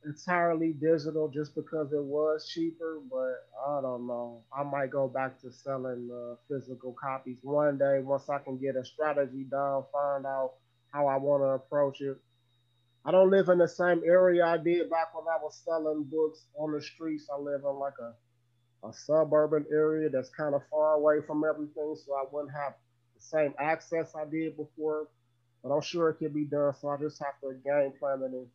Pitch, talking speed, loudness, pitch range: 145 Hz, 200 wpm, -30 LUFS, 135-155 Hz